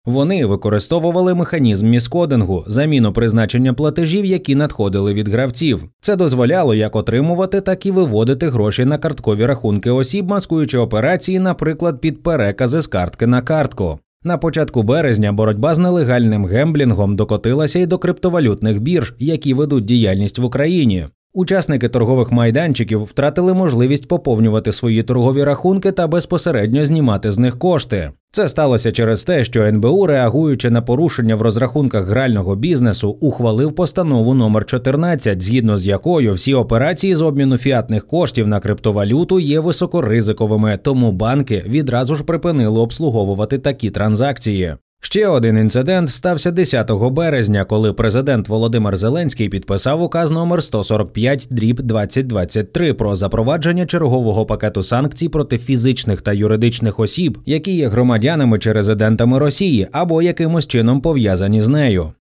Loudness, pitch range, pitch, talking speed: -15 LUFS, 110-160 Hz, 125 Hz, 135 wpm